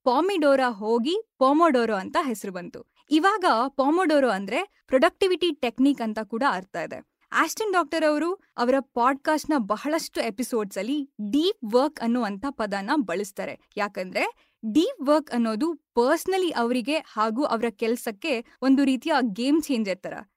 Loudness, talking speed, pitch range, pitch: -24 LUFS, 125 wpm, 230-315 Hz, 270 Hz